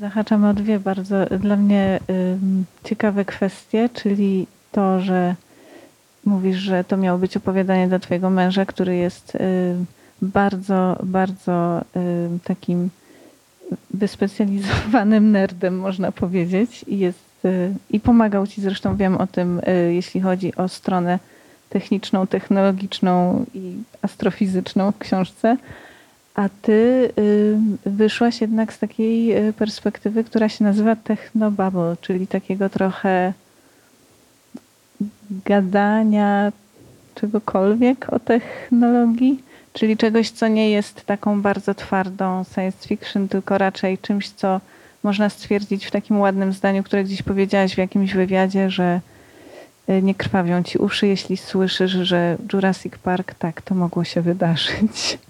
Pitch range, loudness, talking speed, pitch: 185-210 Hz, -20 LUFS, 125 wpm, 195 Hz